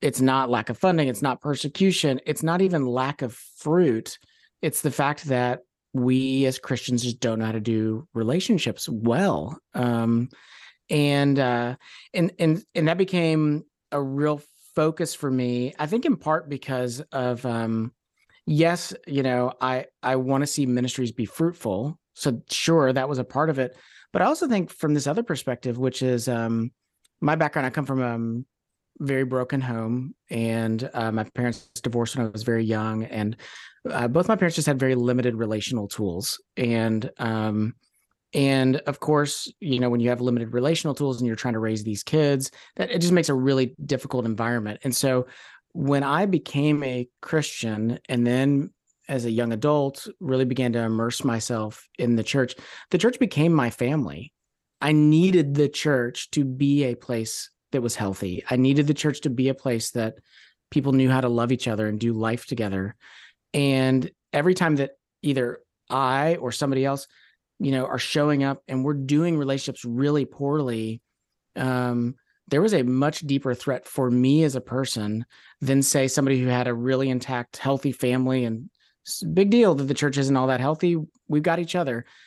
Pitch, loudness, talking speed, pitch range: 130 Hz, -24 LUFS, 185 wpm, 120-150 Hz